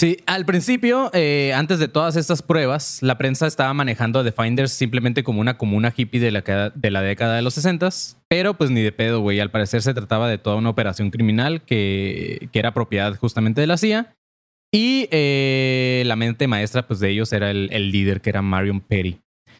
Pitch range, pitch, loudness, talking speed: 105-150 Hz, 120 Hz, -20 LUFS, 210 wpm